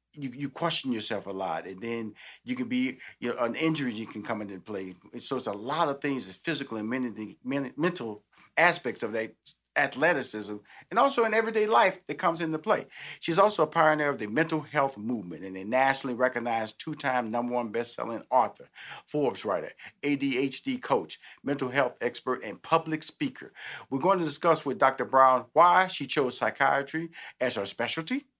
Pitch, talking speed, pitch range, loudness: 135 Hz, 185 wpm, 120-165 Hz, -28 LUFS